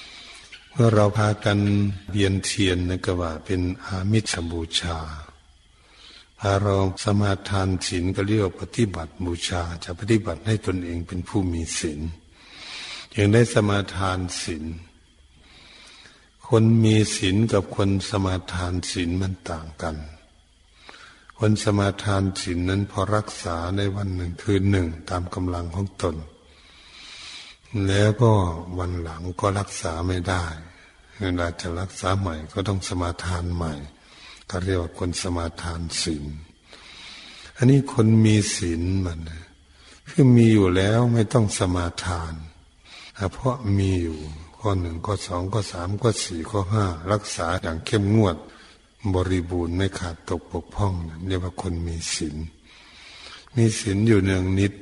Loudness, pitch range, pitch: -24 LUFS, 85-100 Hz, 90 Hz